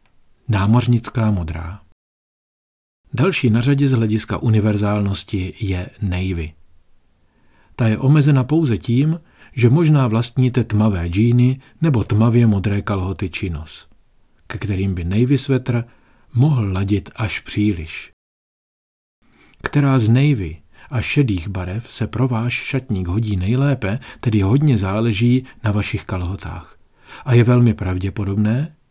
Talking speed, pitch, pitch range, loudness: 115 wpm, 110 Hz, 95-125 Hz, -18 LUFS